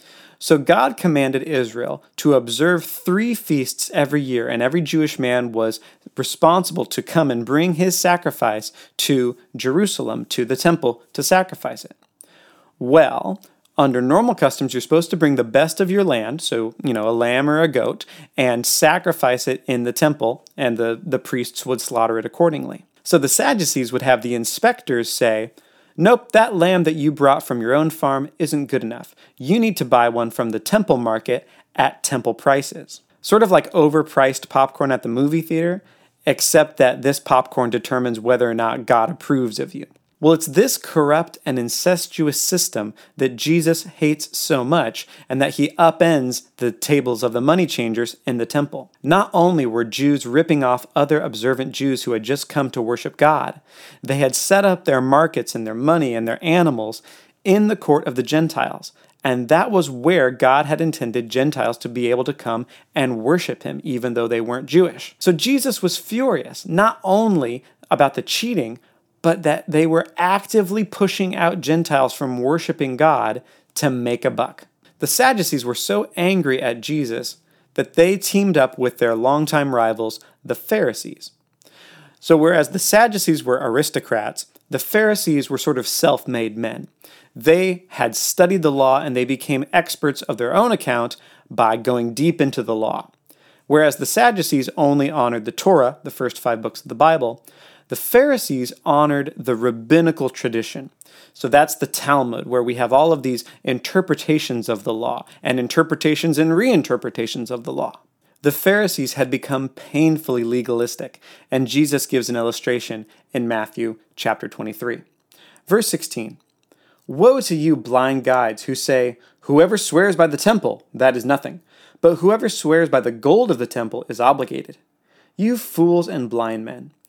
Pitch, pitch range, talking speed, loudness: 140 Hz, 125-165 Hz, 170 wpm, -18 LUFS